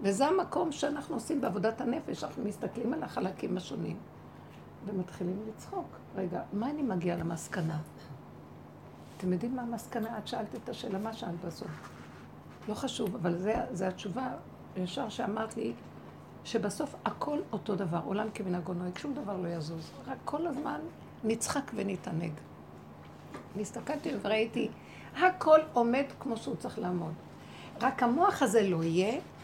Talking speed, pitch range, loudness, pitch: 135 wpm, 175-245 Hz, -33 LUFS, 215 Hz